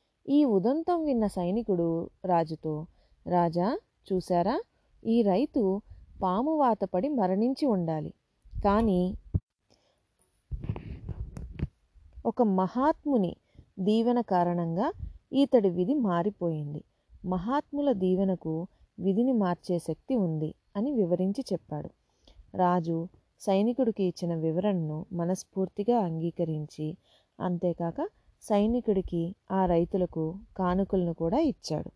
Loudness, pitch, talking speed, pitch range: -29 LUFS, 190 Hz, 80 wpm, 175-235 Hz